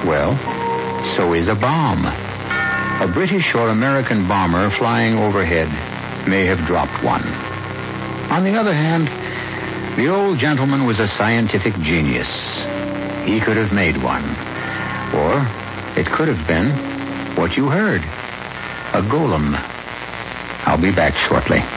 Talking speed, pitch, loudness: 125 wpm, 95 Hz, -18 LUFS